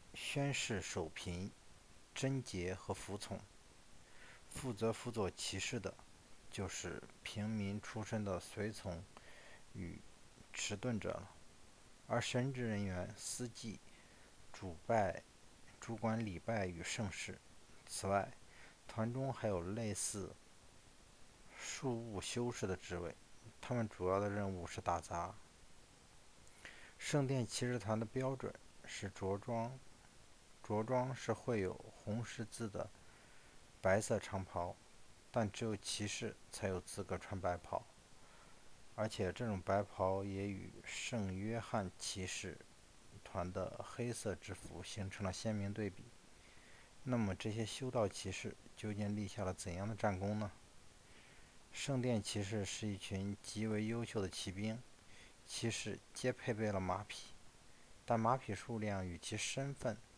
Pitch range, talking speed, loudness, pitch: 95-115 Hz, 180 characters per minute, -42 LUFS, 105 Hz